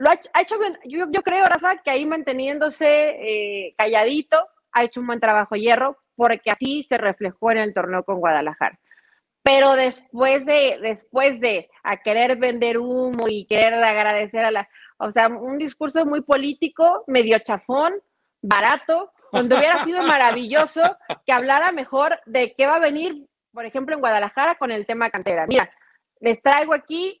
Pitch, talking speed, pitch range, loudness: 265 Hz, 165 wpm, 230-310 Hz, -20 LUFS